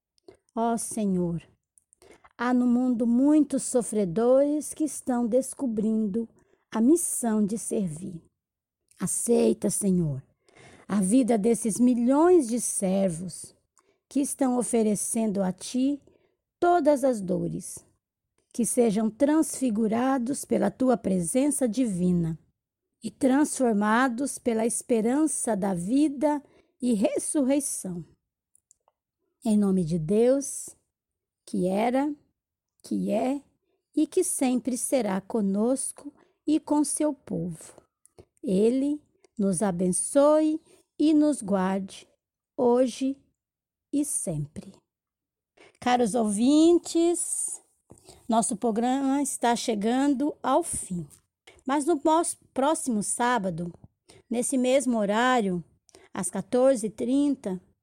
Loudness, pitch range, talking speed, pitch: -25 LUFS, 205-285 Hz, 90 wpm, 245 Hz